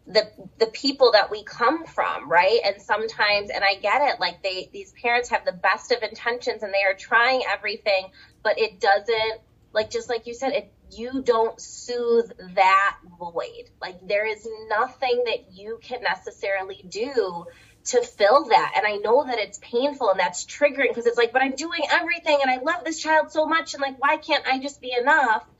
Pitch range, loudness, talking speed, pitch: 205-280 Hz, -22 LUFS, 200 wpm, 235 Hz